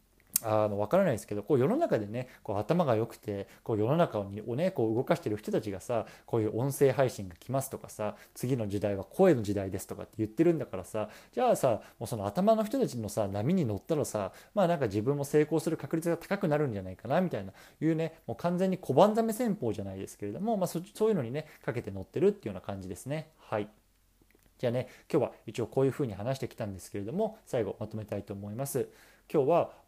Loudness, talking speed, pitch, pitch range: -31 LUFS, 475 characters per minute, 120 Hz, 105-160 Hz